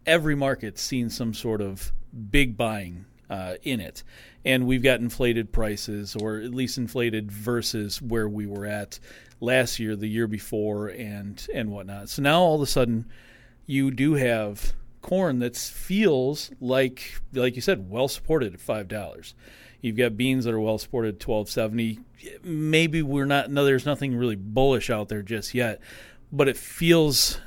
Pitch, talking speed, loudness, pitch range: 120 Hz, 175 wpm, -25 LUFS, 110-135 Hz